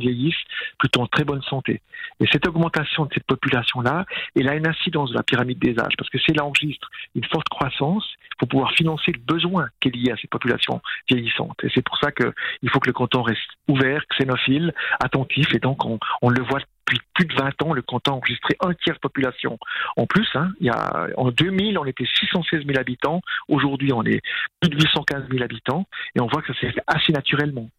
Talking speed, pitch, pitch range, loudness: 225 wpm, 140 Hz, 125-160 Hz, -21 LUFS